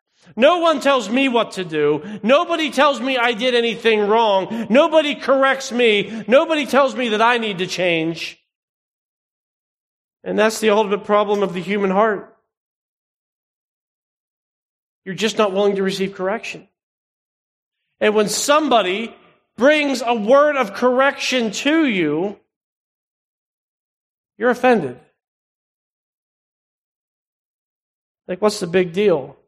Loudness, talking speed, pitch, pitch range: -17 LUFS, 120 wpm, 225 Hz, 200-270 Hz